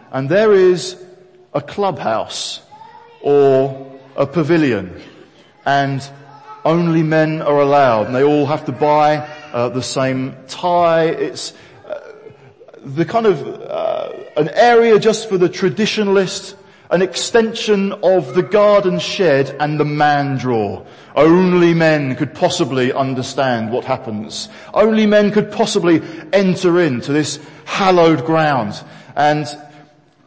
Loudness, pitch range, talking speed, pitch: -15 LUFS, 140-190 Hz, 125 wpm, 160 Hz